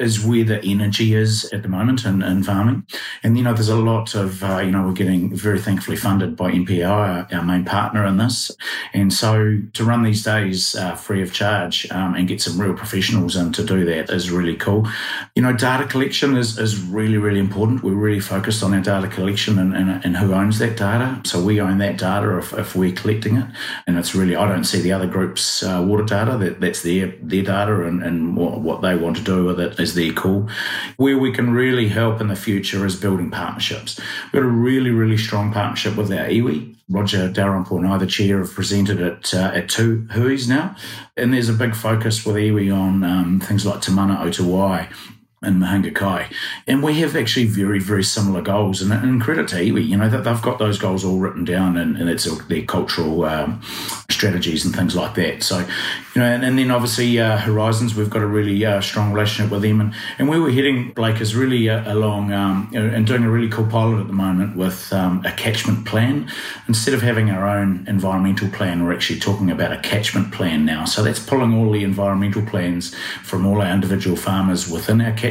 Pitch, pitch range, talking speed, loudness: 100 Hz, 95-110 Hz, 220 wpm, -19 LUFS